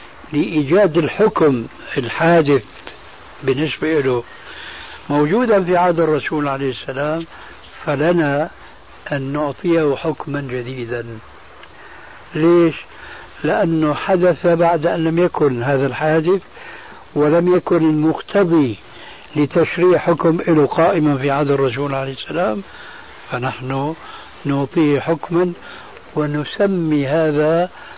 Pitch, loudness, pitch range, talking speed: 155 Hz, -17 LUFS, 140-170 Hz, 90 wpm